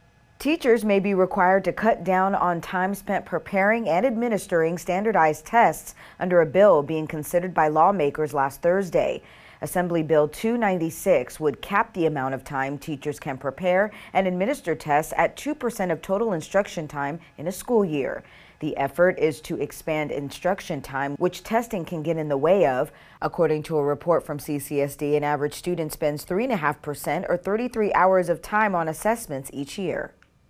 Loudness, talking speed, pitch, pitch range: -24 LUFS, 165 wpm, 170 Hz, 150-195 Hz